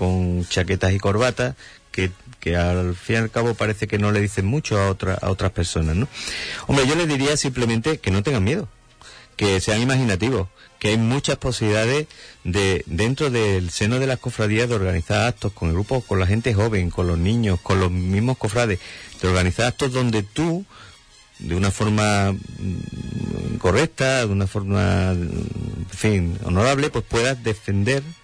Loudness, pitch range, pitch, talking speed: -21 LUFS, 95-120 Hz, 105 Hz, 170 wpm